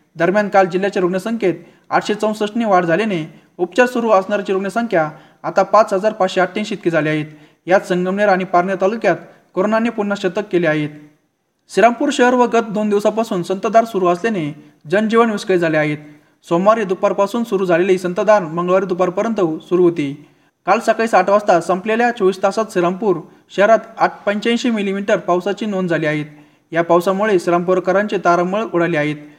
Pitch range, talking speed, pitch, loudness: 170-210 Hz, 150 wpm, 190 Hz, -16 LUFS